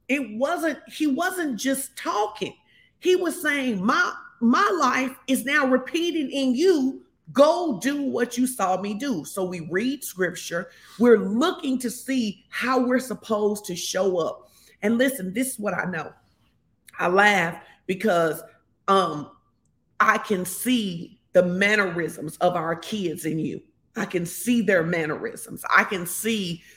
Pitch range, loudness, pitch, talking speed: 190-265 Hz, -24 LUFS, 225 Hz, 150 wpm